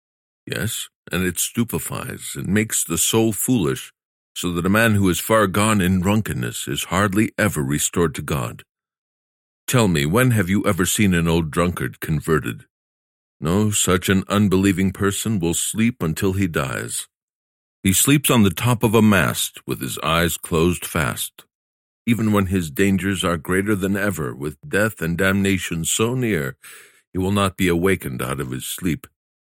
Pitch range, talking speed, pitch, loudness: 85-105 Hz, 165 wpm, 95 Hz, -20 LUFS